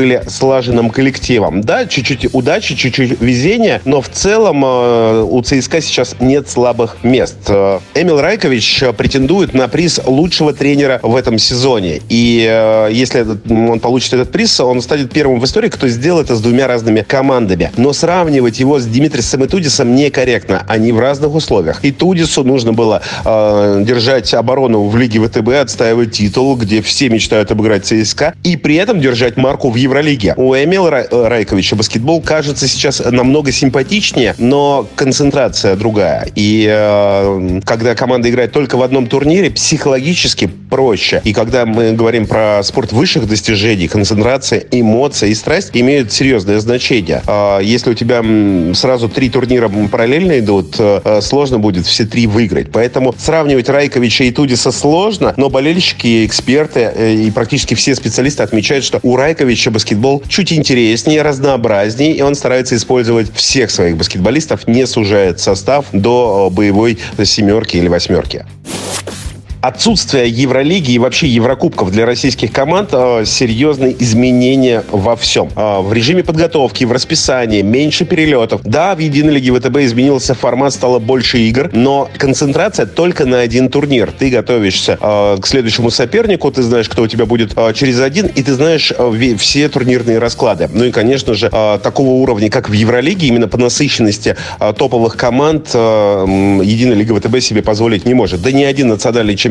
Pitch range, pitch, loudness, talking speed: 110-140 Hz, 125 Hz, -11 LUFS, 150 wpm